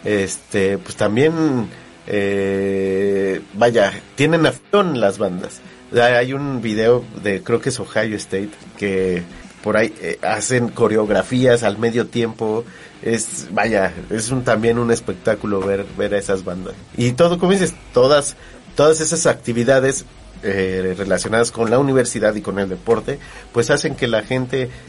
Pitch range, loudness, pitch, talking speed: 100-130 Hz, -18 LUFS, 115 Hz, 145 wpm